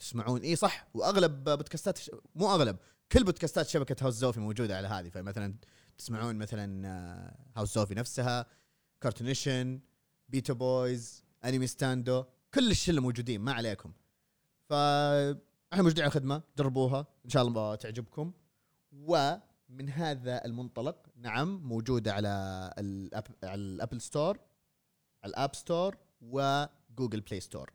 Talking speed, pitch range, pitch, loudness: 120 wpm, 115-145 Hz, 130 Hz, -33 LUFS